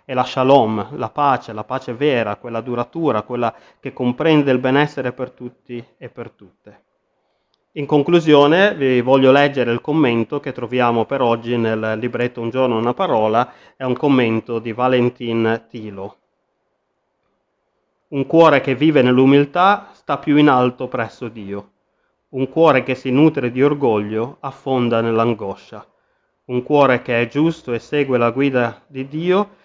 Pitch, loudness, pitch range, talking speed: 125 Hz, -17 LUFS, 120-140 Hz, 150 wpm